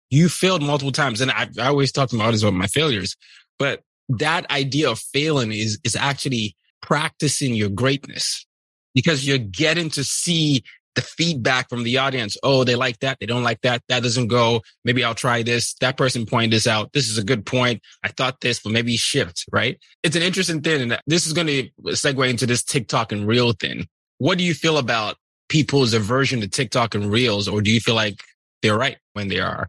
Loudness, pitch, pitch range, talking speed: -20 LUFS, 125 Hz, 115-140 Hz, 210 wpm